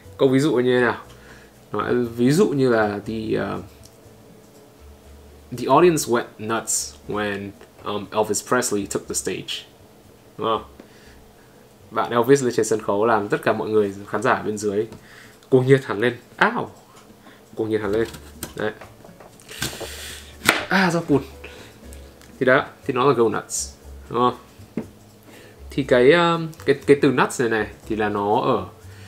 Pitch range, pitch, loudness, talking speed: 100-125 Hz, 110 Hz, -21 LUFS, 160 wpm